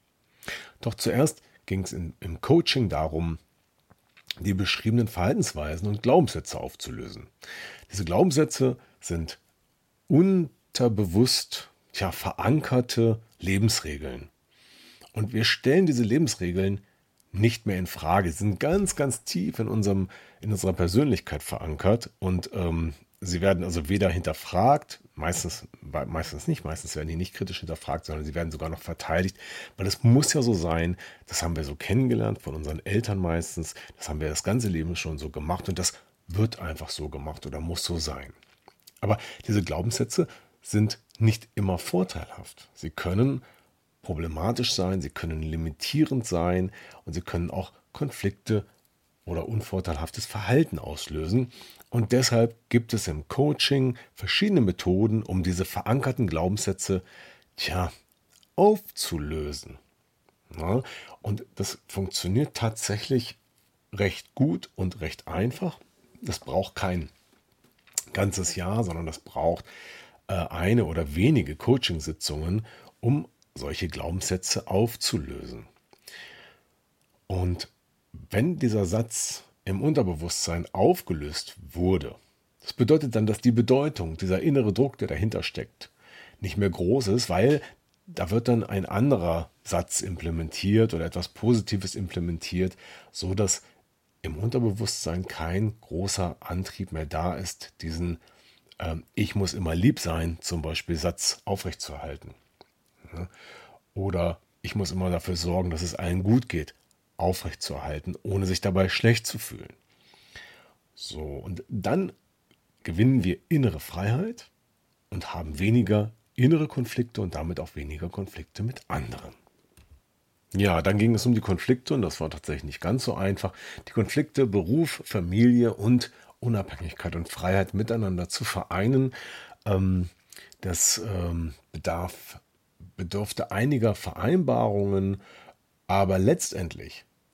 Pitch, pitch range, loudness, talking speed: 95 Hz, 85-115 Hz, -27 LUFS, 125 wpm